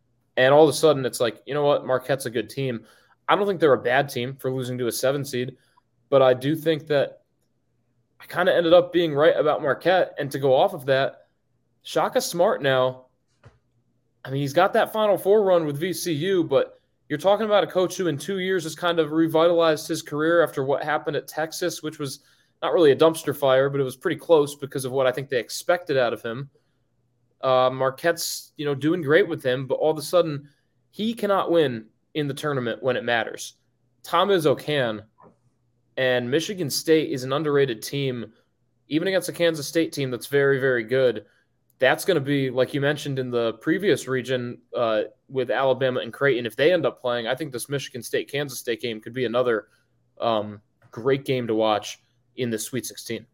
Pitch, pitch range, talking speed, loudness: 140 Hz, 125-160 Hz, 210 wpm, -23 LUFS